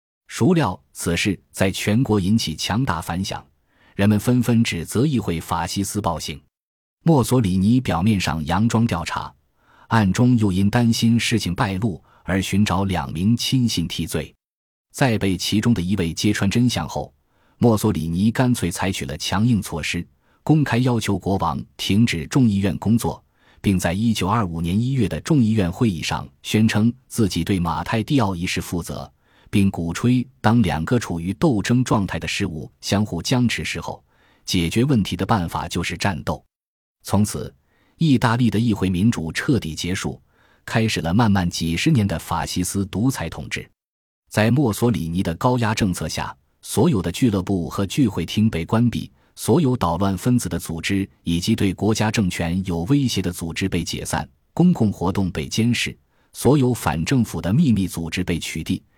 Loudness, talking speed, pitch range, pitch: -21 LUFS, 255 characters per minute, 85-115 Hz, 100 Hz